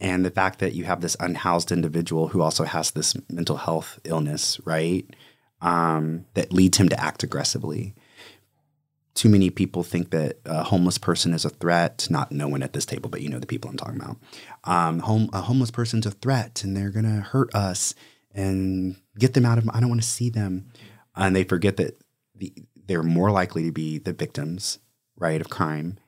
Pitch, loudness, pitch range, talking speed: 95 Hz, -24 LUFS, 85-110 Hz, 195 wpm